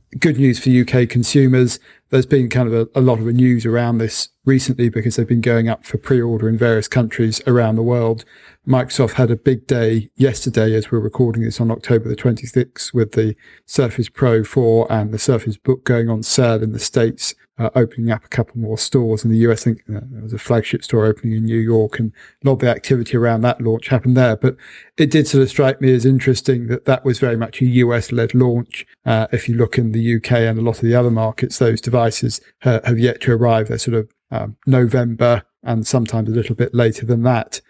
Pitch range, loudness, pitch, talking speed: 115-125 Hz, -17 LUFS, 120 Hz, 220 wpm